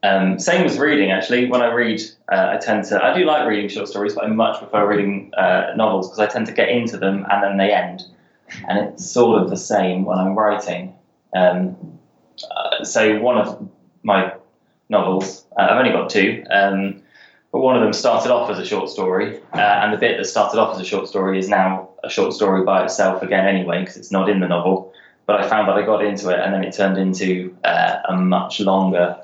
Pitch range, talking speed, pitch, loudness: 95-105 Hz, 230 wpm, 95 Hz, -18 LUFS